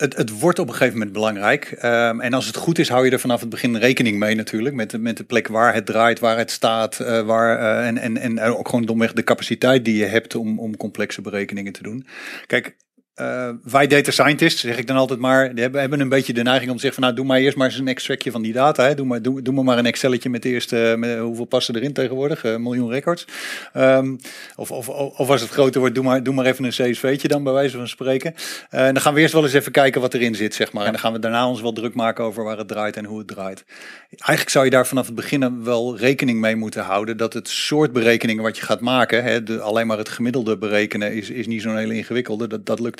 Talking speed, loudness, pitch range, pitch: 270 wpm, -19 LUFS, 115-130 Hz, 120 Hz